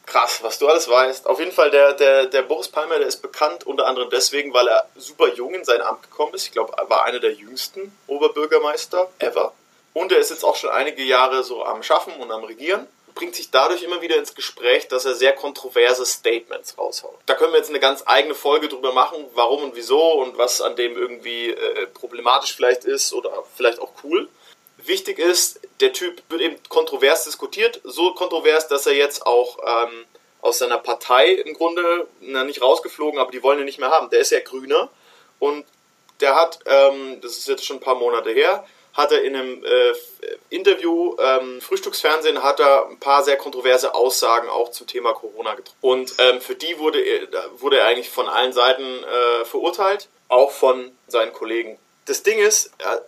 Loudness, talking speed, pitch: -19 LUFS, 200 wpm, 380 Hz